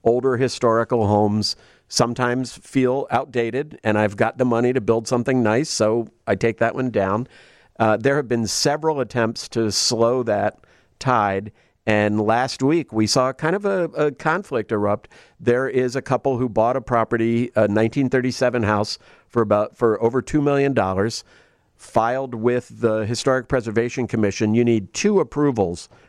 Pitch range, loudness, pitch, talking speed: 110-130 Hz, -21 LUFS, 120 Hz, 160 wpm